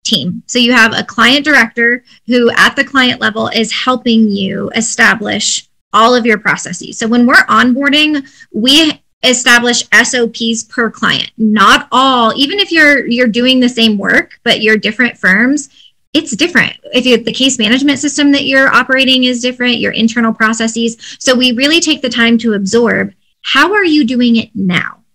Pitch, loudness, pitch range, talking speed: 245 Hz, -10 LUFS, 230-270 Hz, 175 wpm